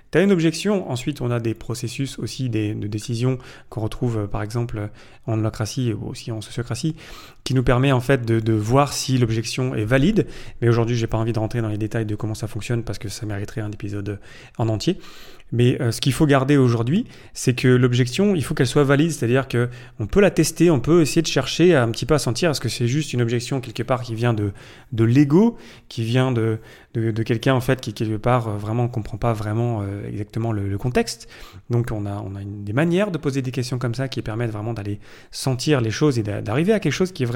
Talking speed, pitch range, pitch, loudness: 240 wpm, 110-135 Hz, 120 Hz, -21 LUFS